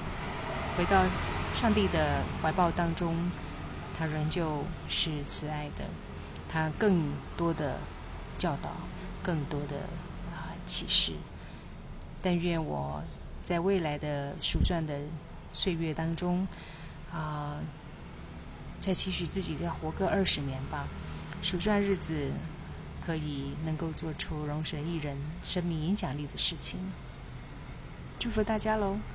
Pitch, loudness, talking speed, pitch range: 155 Hz, -28 LUFS, 175 characters per minute, 140-175 Hz